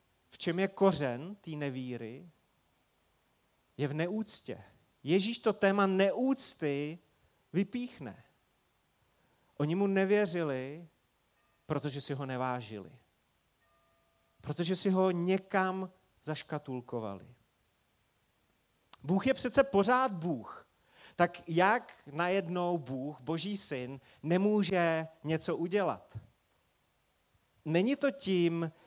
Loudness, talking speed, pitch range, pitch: -32 LUFS, 90 wpm, 135-195 Hz, 170 Hz